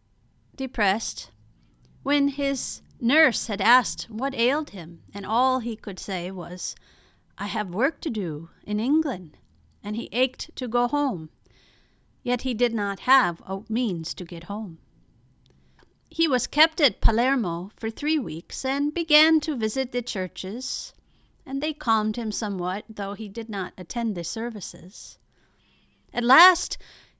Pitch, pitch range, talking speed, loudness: 225 Hz, 185-265 Hz, 145 wpm, -25 LUFS